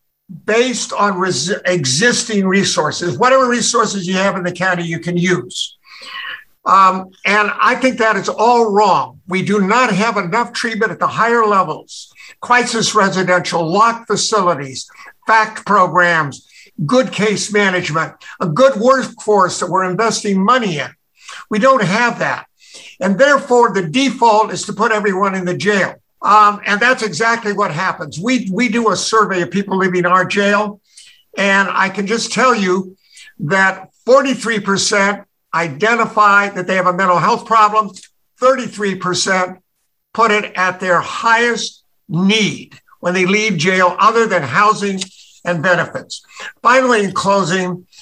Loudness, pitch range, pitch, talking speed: -14 LUFS, 185-225 Hz, 205 Hz, 150 wpm